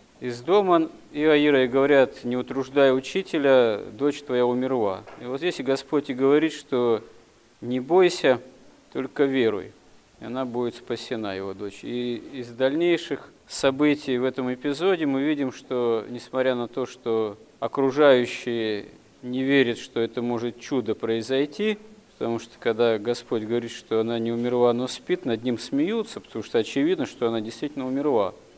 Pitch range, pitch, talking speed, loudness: 120-145 Hz, 130 Hz, 150 wpm, -24 LUFS